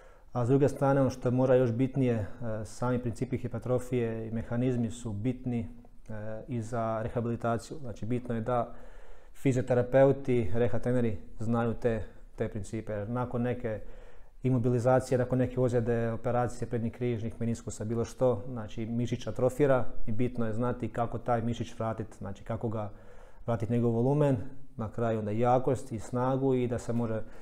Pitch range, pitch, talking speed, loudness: 115-125 Hz, 120 Hz, 155 wpm, -31 LUFS